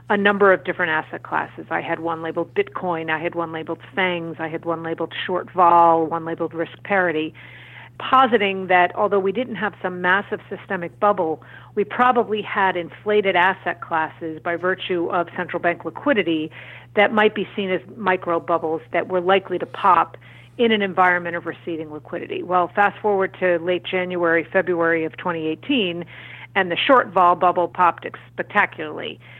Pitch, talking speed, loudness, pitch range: 180 Hz, 165 wpm, -20 LUFS, 165-195 Hz